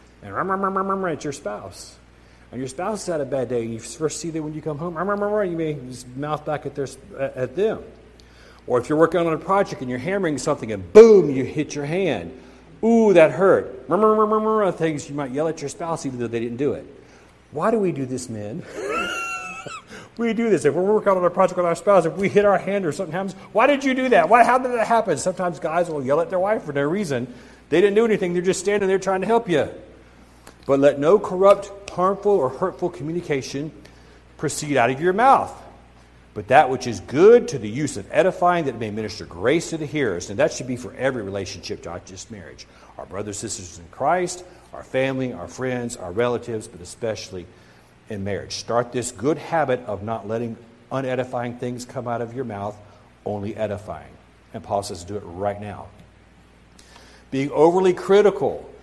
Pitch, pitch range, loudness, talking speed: 145 Hz, 115-190 Hz, -21 LUFS, 205 wpm